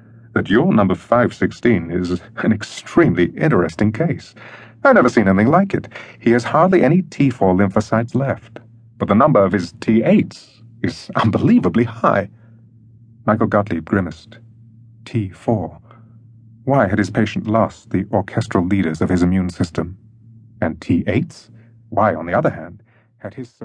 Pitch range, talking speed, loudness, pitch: 100-115 Hz, 140 wpm, -17 LUFS, 115 Hz